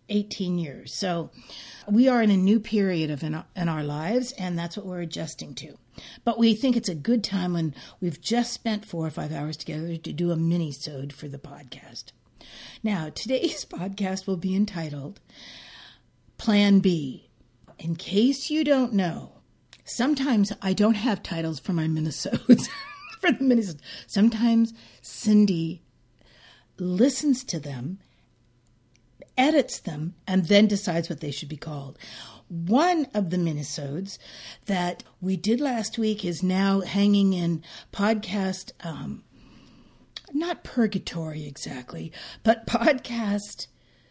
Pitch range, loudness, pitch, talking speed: 160-225 Hz, -25 LUFS, 190 Hz, 140 wpm